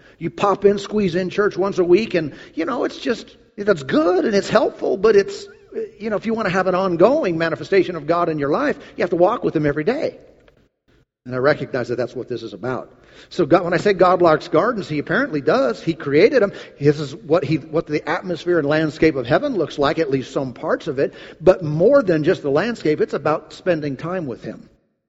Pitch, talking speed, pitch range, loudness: 175 Hz, 235 wpm, 155-200 Hz, -19 LUFS